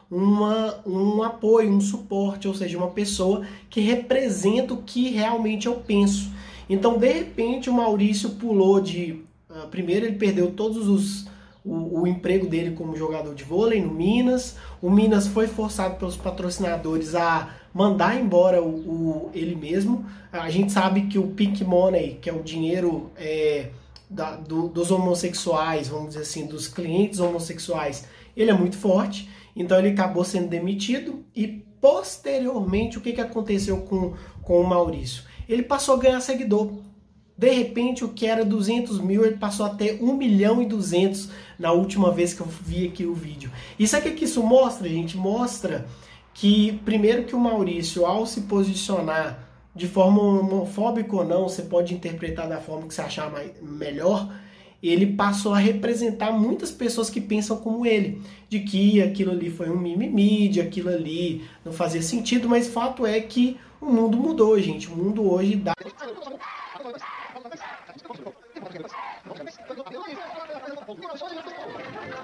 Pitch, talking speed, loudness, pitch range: 200 Hz, 155 wpm, -23 LUFS, 175-225 Hz